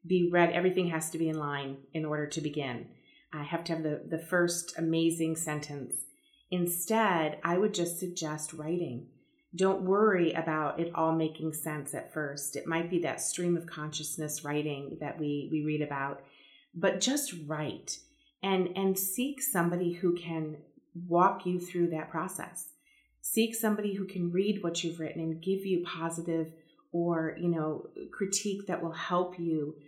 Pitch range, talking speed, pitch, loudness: 155-180 Hz, 165 wpm, 165 Hz, -32 LUFS